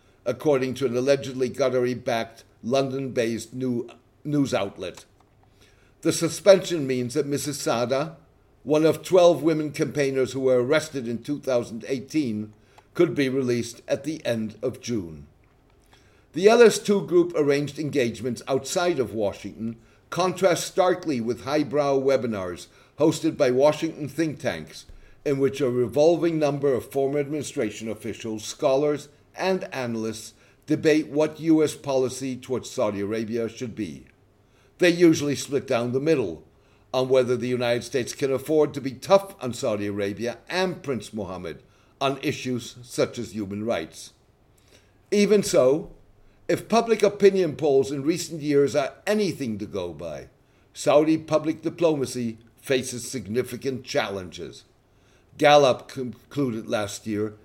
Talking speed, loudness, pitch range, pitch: 130 wpm, -24 LUFS, 115-155 Hz, 130 Hz